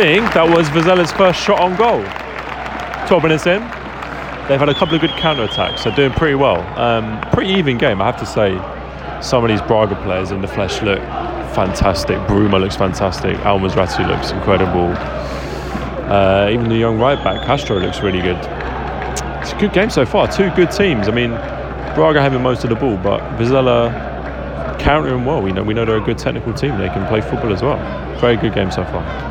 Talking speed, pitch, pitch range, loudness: 200 wpm, 115 Hz, 95-140 Hz, -16 LUFS